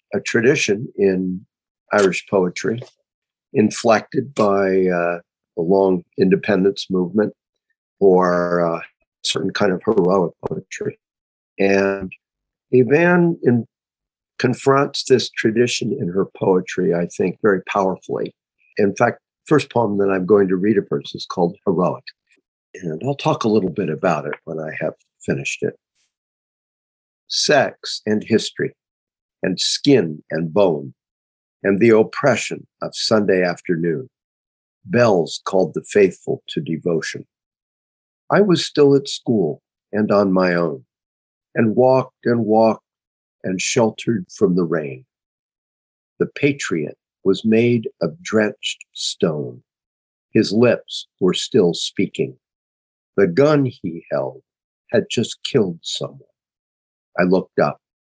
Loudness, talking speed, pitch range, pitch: -19 LUFS, 125 wpm, 85-125 Hz, 100 Hz